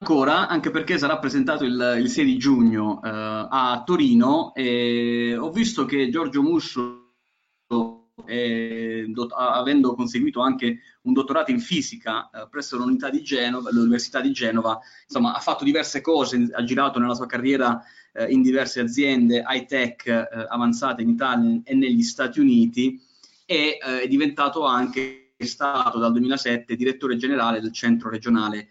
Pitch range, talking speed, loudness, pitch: 120-155 Hz, 155 wpm, -22 LUFS, 125 Hz